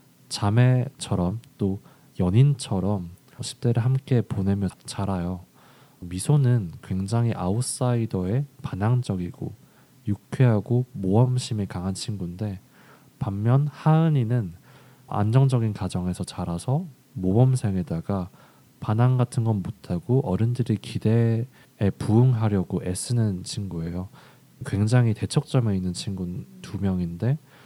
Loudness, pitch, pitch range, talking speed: -25 LUFS, 110 Hz, 95-130 Hz, 250 characters per minute